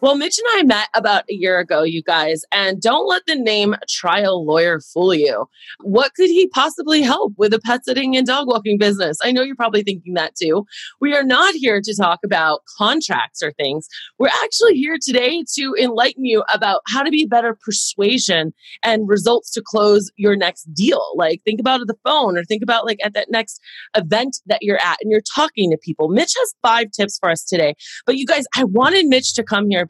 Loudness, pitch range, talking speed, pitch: -16 LUFS, 200-265 Hz, 215 wpm, 225 Hz